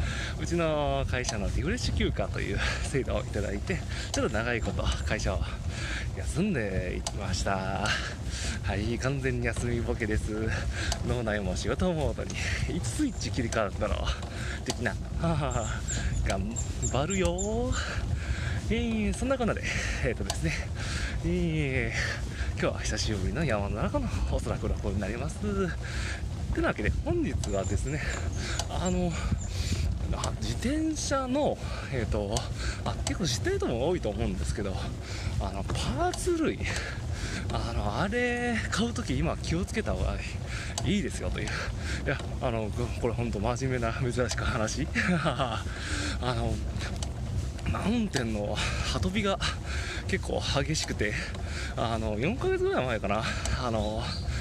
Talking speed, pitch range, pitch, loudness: 270 characters per minute, 95-120 Hz, 105 Hz, -30 LUFS